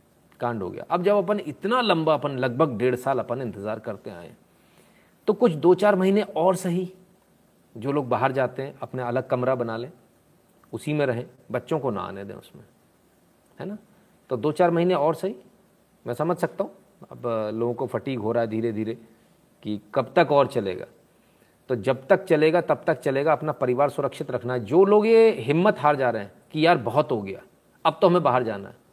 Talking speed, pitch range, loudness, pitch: 205 wpm, 120-180 Hz, -24 LUFS, 145 Hz